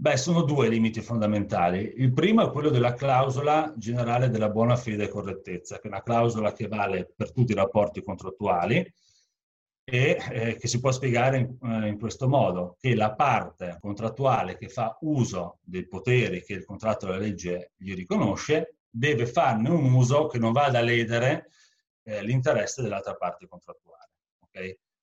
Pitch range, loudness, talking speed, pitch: 100-130 Hz, -26 LUFS, 160 wpm, 115 Hz